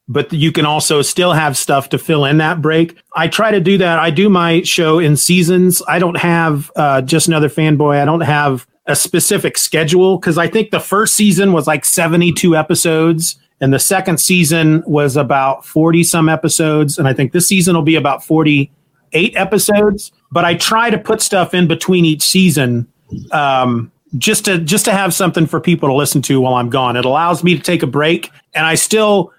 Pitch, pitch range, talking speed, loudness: 165 Hz, 150-180 Hz, 210 wpm, -12 LUFS